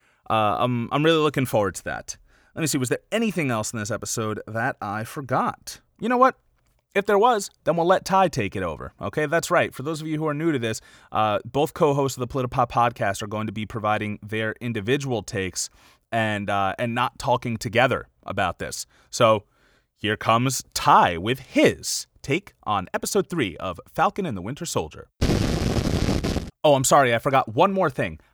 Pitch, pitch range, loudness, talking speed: 125 Hz, 110-155 Hz, -23 LUFS, 200 wpm